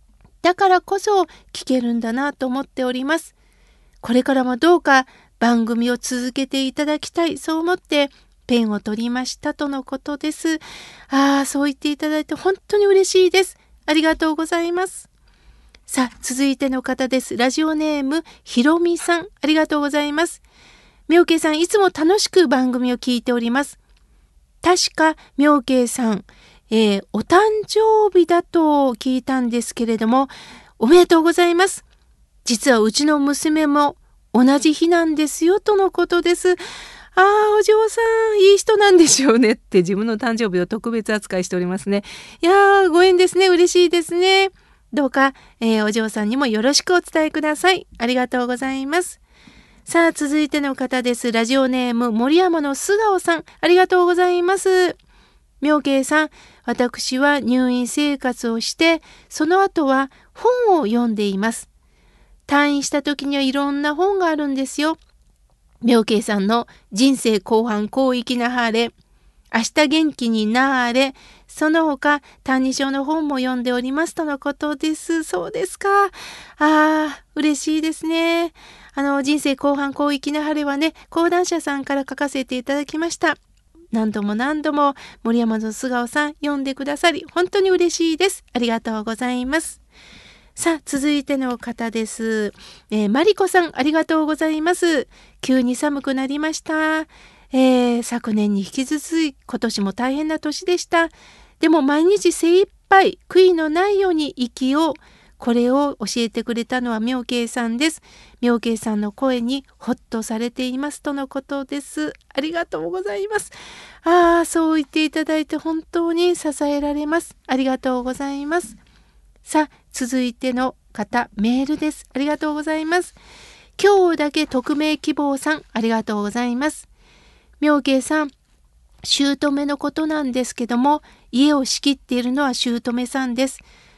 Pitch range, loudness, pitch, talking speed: 250-330 Hz, -19 LUFS, 290 Hz, 315 characters per minute